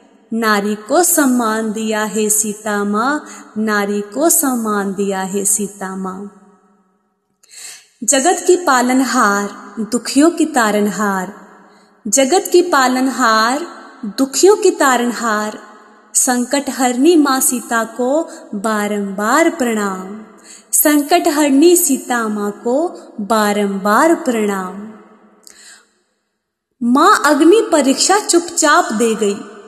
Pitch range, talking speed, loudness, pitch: 210-290 Hz, 95 wpm, -14 LUFS, 235 Hz